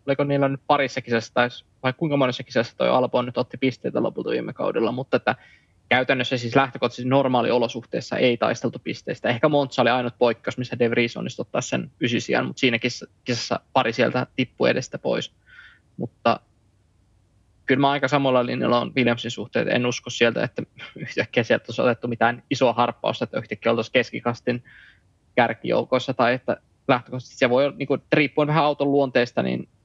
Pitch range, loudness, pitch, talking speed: 120-135 Hz, -23 LUFS, 125 Hz, 170 wpm